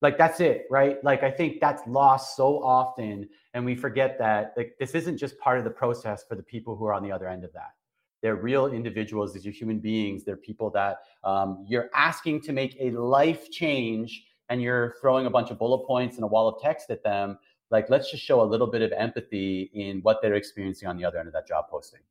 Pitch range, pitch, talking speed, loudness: 105-135 Hz, 115 Hz, 240 wpm, -26 LUFS